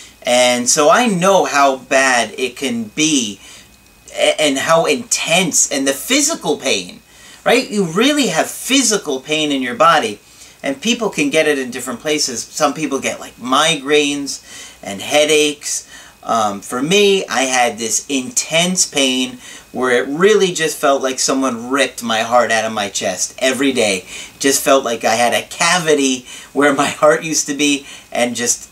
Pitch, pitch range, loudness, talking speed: 145 Hz, 130-170 Hz, -15 LUFS, 165 wpm